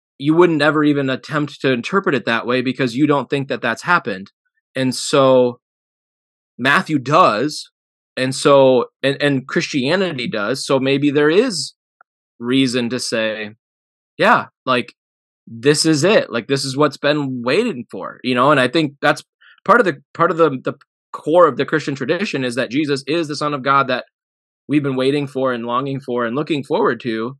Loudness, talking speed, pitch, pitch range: -17 LUFS, 185 wpm, 135 Hz, 125-150 Hz